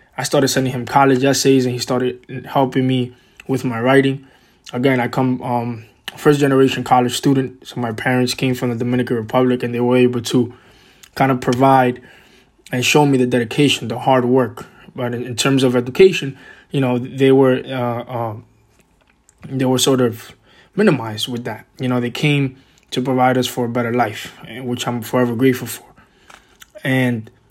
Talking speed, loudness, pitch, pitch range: 175 wpm, -17 LUFS, 125 Hz, 120-135 Hz